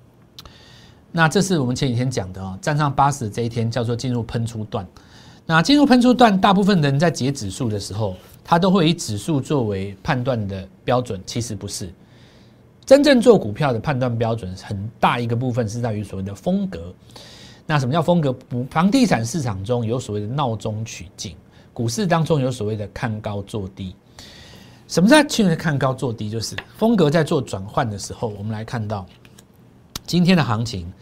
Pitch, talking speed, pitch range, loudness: 120 Hz, 285 characters per minute, 105-160 Hz, -20 LUFS